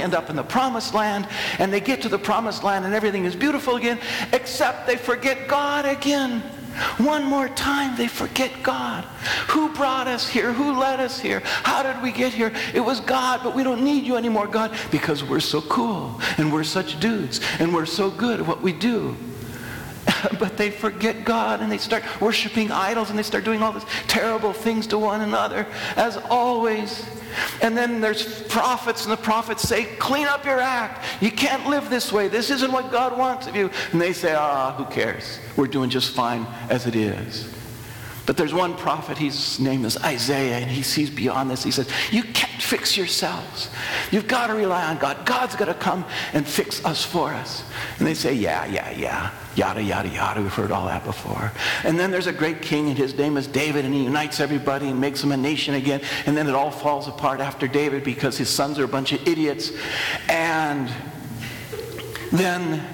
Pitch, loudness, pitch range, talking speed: 195 Hz, -23 LUFS, 140-235 Hz, 205 wpm